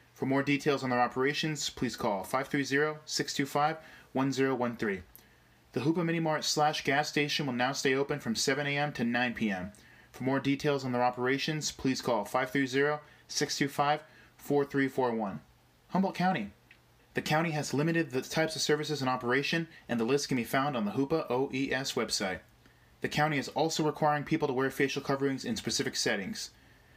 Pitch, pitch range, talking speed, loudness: 140 Hz, 130-150 Hz, 160 wpm, -31 LUFS